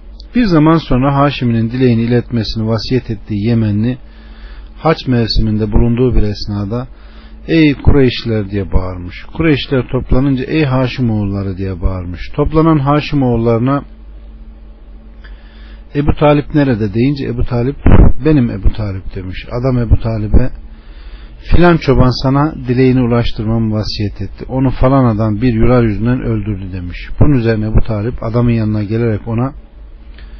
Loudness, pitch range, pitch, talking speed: -14 LUFS, 105-130 Hz, 115 Hz, 125 wpm